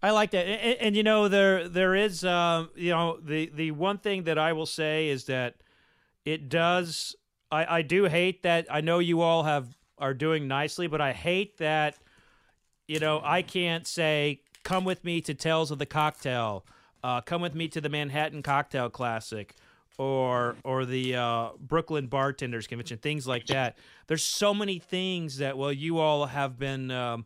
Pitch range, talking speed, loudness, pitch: 135-175 Hz, 185 wpm, -28 LUFS, 155 Hz